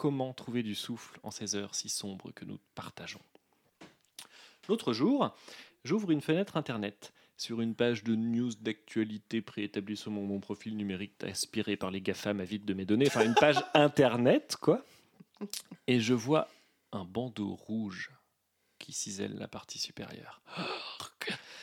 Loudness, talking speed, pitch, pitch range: -33 LUFS, 155 wpm, 110 Hz, 105-125 Hz